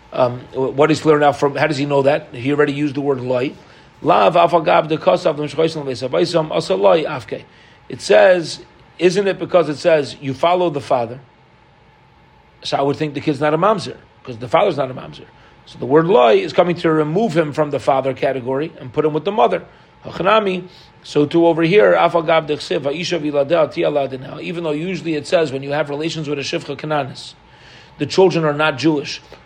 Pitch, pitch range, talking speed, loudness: 155 Hz, 140-170 Hz, 170 wpm, -17 LUFS